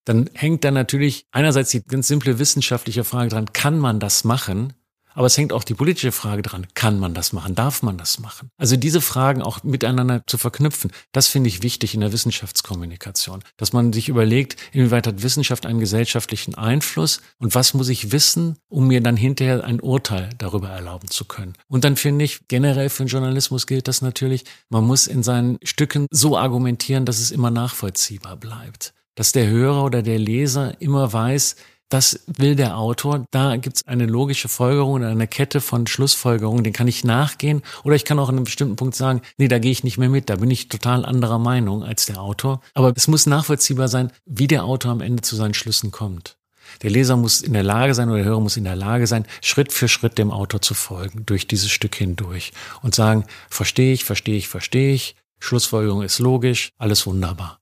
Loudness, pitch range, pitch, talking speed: -19 LUFS, 110-135 Hz, 125 Hz, 205 wpm